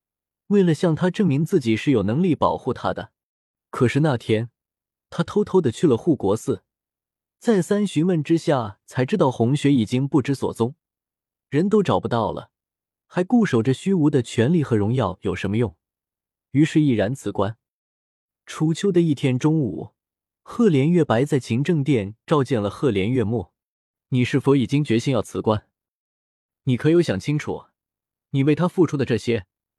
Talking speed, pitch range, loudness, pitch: 240 characters per minute, 110-155 Hz, -21 LUFS, 130 Hz